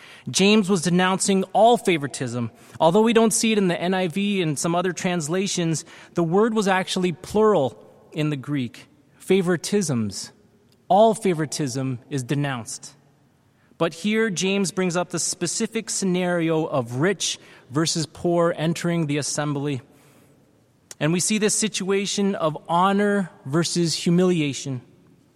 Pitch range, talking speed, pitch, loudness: 145-190 Hz, 130 wpm, 170 Hz, -22 LUFS